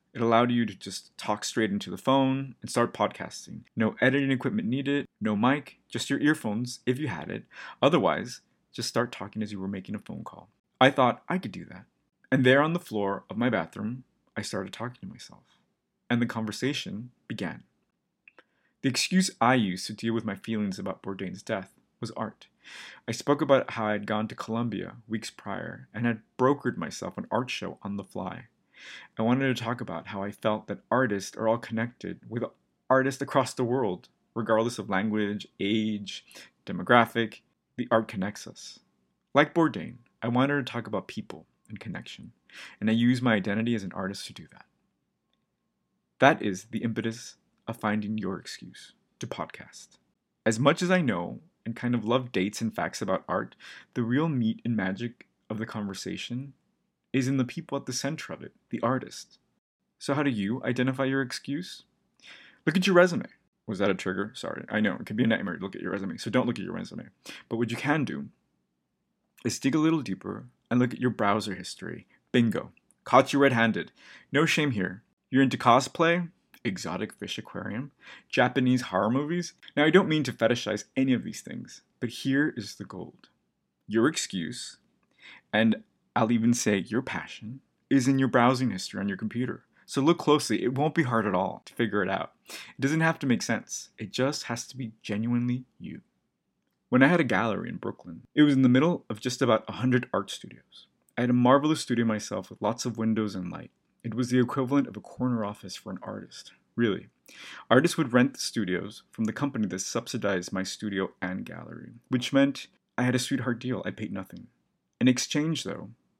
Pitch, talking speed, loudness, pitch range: 120 Hz, 195 wpm, -28 LUFS, 110-135 Hz